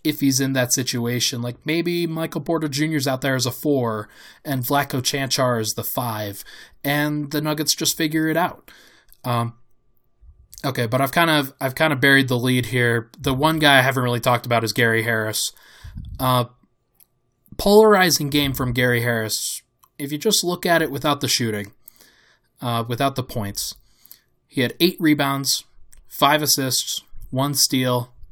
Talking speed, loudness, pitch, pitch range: 170 wpm, -20 LUFS, 130 Hz, 120-150 Hz